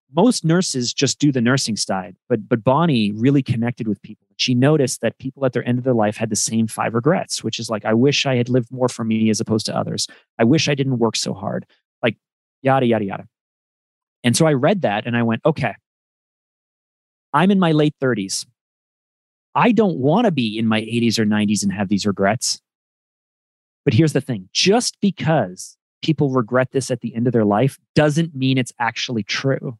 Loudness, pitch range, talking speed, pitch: -19 LUFS, 110-140 Hz, 205 wpm, 125 Hz